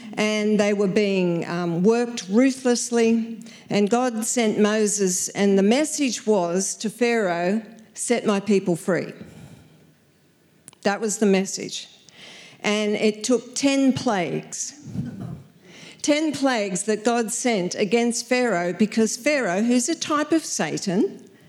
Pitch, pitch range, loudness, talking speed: 220 Hz, 205-240 Hz, -22 LUFS, 125 wpm